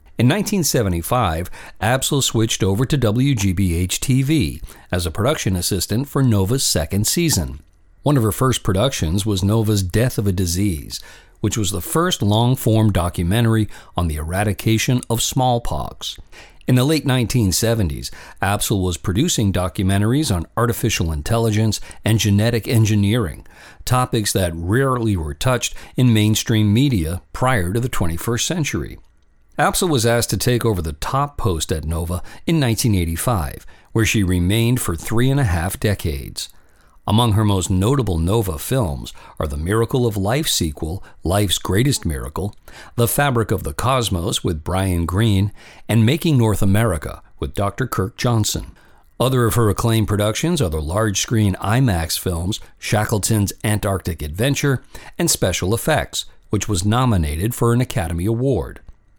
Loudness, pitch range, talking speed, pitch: -19 LUFS, 90-120 Hz, 145 wpm, 105 Hz